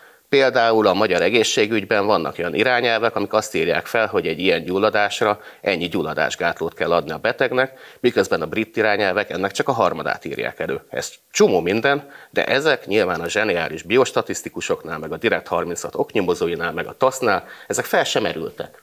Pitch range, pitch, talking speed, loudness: 110-140 Hz, 115 Hz, 165 wpm, -20 LUFS